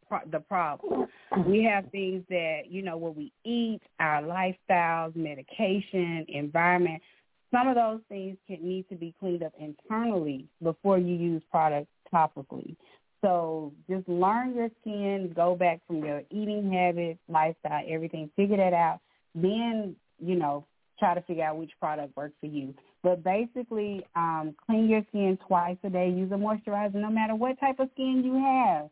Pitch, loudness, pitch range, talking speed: 180 Hz, -29 LUFS, 160-205 Hz, 165 wpm